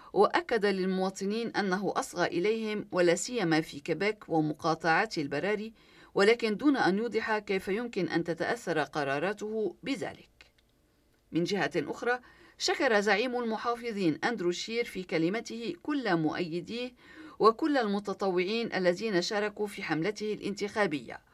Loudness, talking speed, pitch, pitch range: -30 LUFS, 110 wpm, 205 Hz, 175-230 Hz